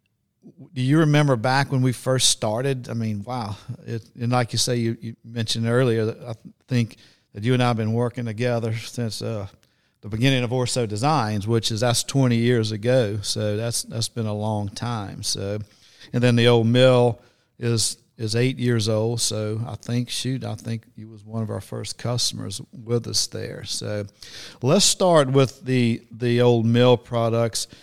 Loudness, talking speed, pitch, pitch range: -22 LUFS, 190 wpm, 115 Hz, 110-125 Hz